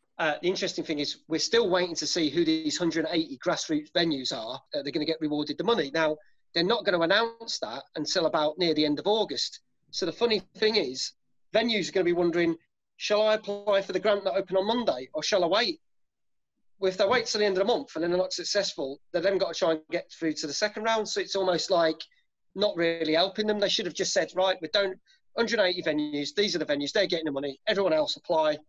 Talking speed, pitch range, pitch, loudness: 250 wpm, 160-210 Hz, 180 Hz, -27 LUFS